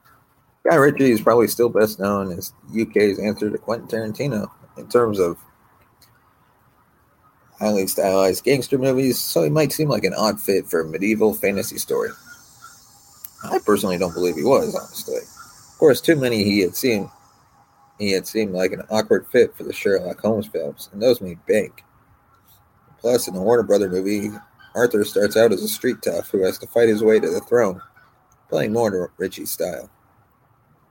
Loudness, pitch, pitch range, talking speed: -20 LUFS, 110 Hz, 100-135 Hz, 175 wpm